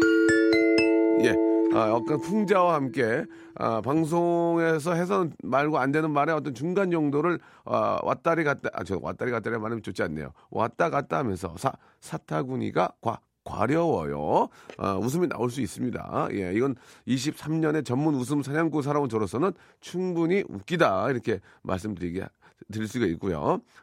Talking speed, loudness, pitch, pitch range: 315 characters per minute, -26 LUFS, 140 Hz, 110-165 Hz